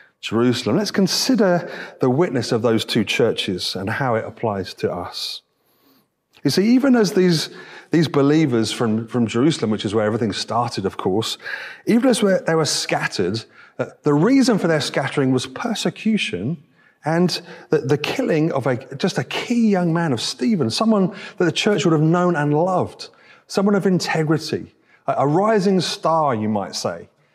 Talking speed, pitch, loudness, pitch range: 170 wpm, 165 Hz, -20 LUFS, 140-200 Hz